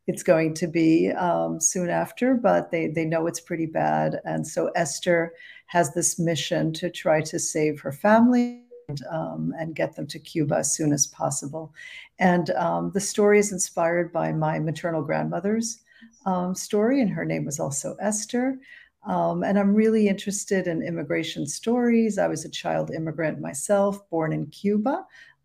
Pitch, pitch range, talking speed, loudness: 170 Hz, 160-205 Hz, 170 wpm, -24 LUFS